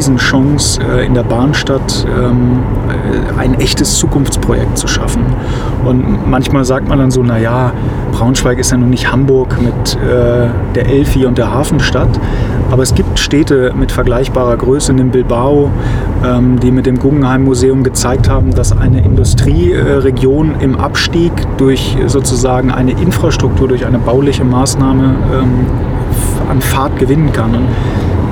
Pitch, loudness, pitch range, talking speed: 125 Hz, -11 LUFS, 120-130 Hz, 130 wpm